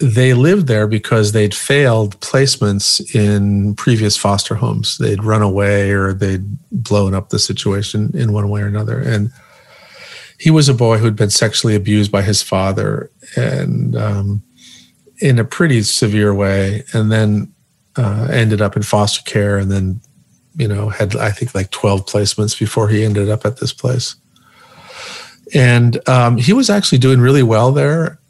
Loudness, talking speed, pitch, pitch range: -14 LUFS, 165 wpm, 110 Hz, 105-130 Hz